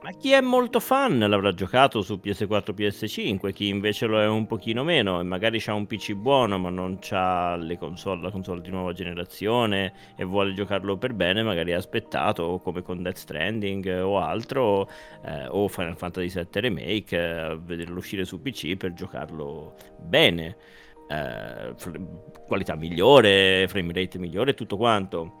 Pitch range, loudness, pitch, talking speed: 90-105 Hz, -25 LUFS, 95 Hz, 170 wpm